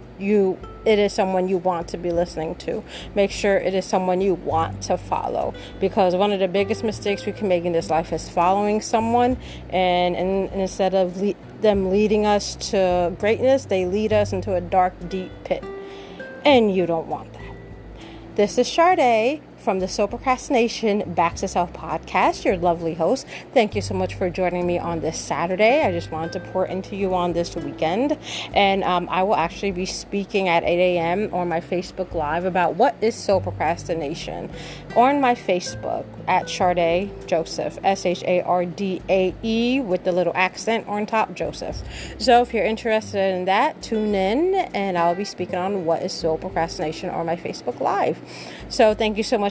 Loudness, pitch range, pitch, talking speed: -22 LUFS, 175-210 Hz, 185 Hz, 180 wpm